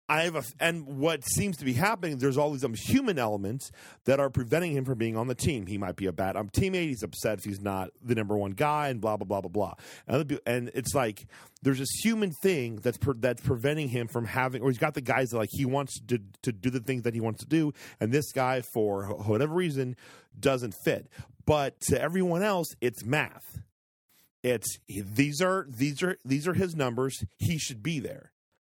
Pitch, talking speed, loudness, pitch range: 130 Hz, 225 wpm, -29 LUFS, 110-145 Hz